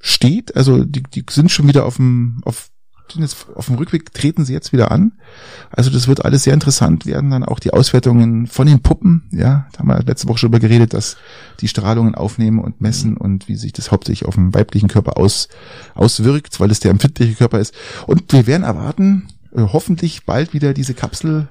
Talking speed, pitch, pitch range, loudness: 210 wpm, 125 Hz, 110-145 Hz, -14 LUFS